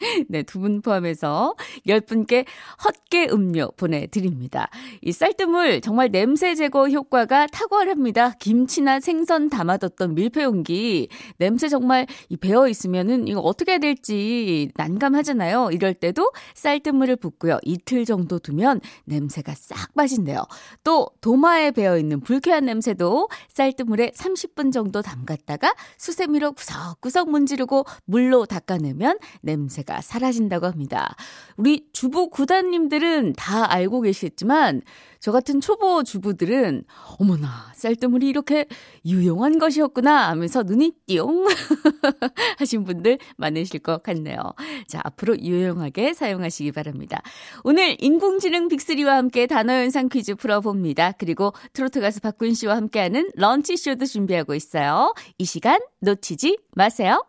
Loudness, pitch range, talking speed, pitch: -21 LUFS, 185-290 Hz, 310 characters per minute, 245 Hz